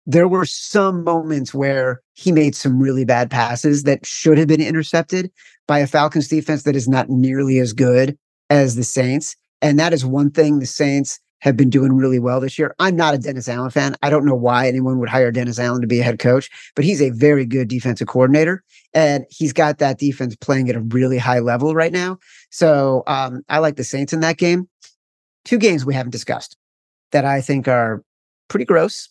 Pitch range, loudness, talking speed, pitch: 130-155 Hz, -17 LUFS, 210 wpm, 140 Hz